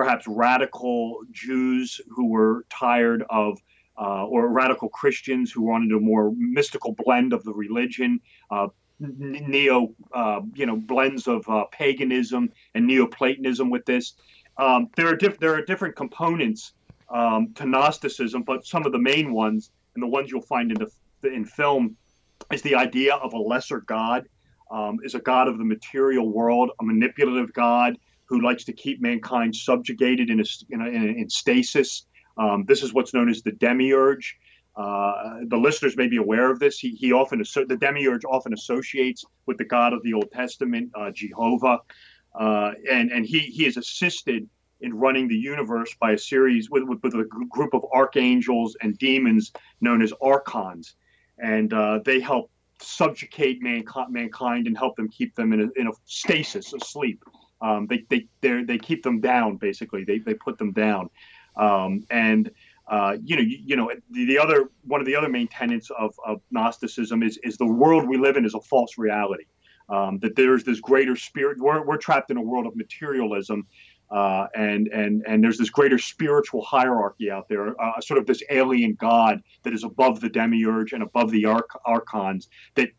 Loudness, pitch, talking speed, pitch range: -23 LUFS, 125 Hz, 180 wpm, 110-145 Hz